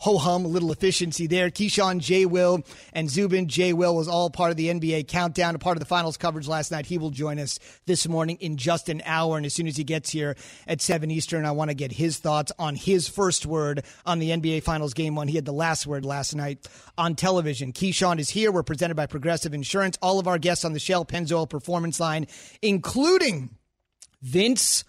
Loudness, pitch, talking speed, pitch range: -25 LUFS, 165 Hz, 225 wpm, 155-180 Hz